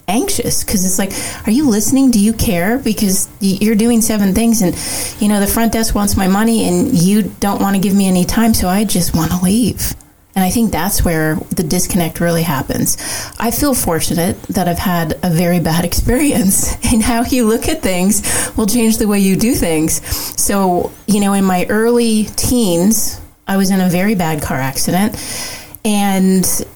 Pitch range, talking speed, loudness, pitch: 180-225 Hz, 195 wpm, -14 LUFS, 205 Hz